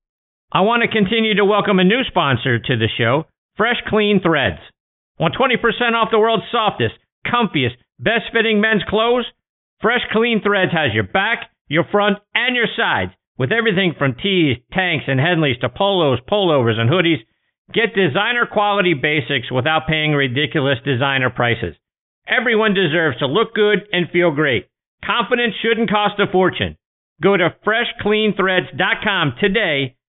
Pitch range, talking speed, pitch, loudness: 140-215 Hz, 150 wpm, 185 Hz, -17 LUFS